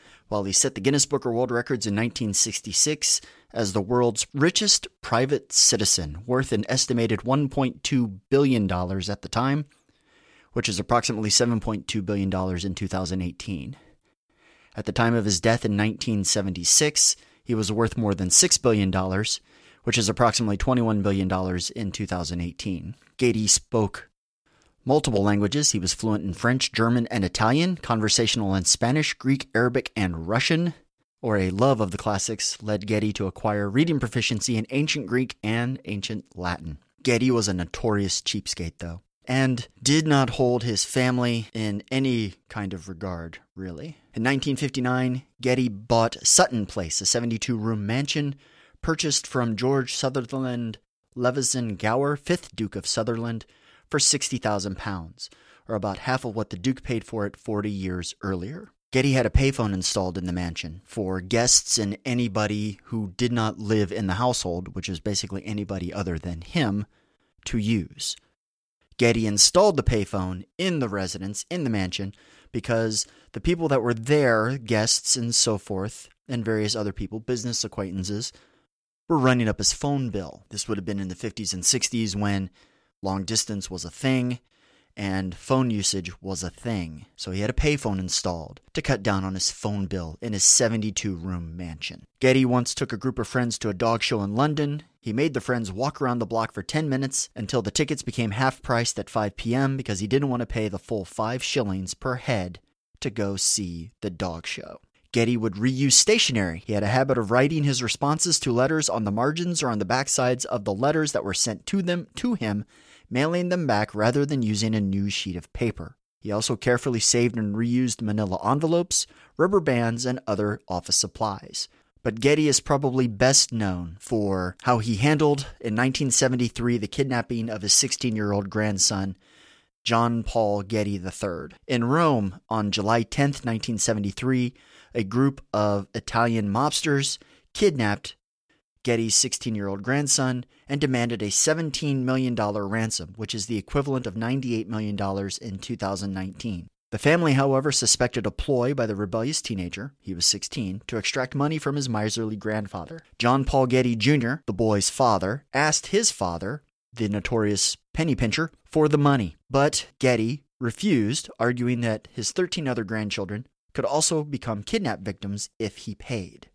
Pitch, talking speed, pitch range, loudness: 115 Hz, 165 wpm, 100-130 Hz, -24 LUFS